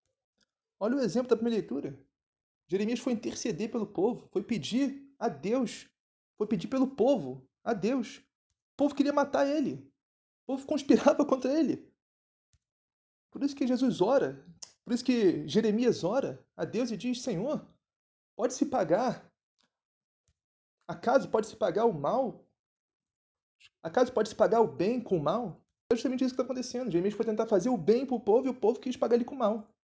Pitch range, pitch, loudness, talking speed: 215-260 Hz, 235 Hz, -30 LUFS, 170 wpm